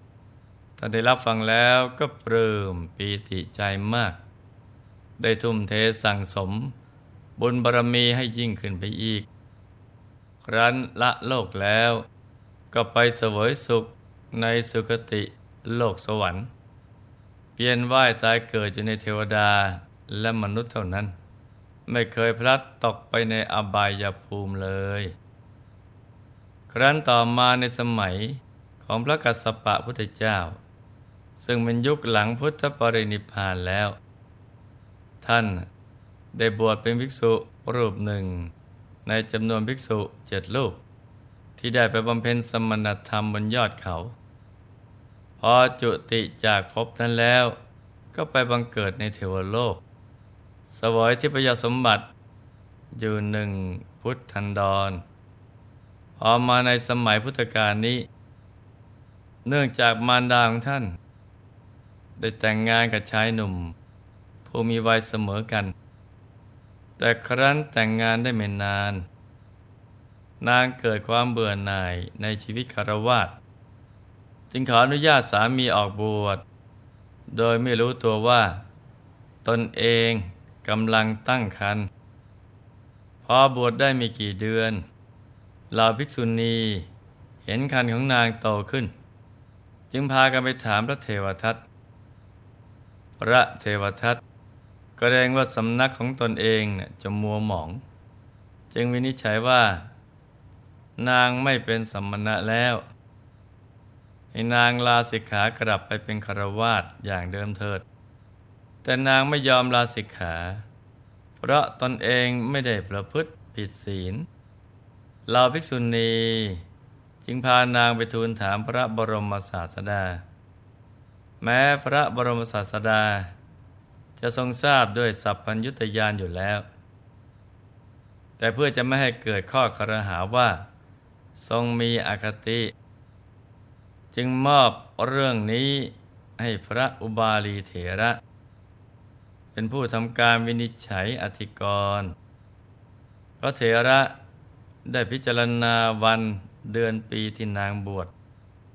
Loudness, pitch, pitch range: -24 LUFS, 110 Hz, 105-120 Hz